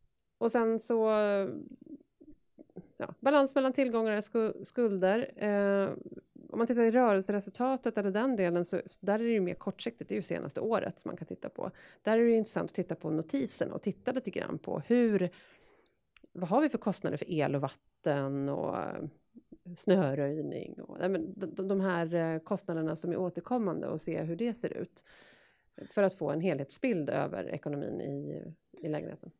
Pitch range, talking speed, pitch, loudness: 175-235 Hz, 175 wpm, 200 Hz, -32 LUFS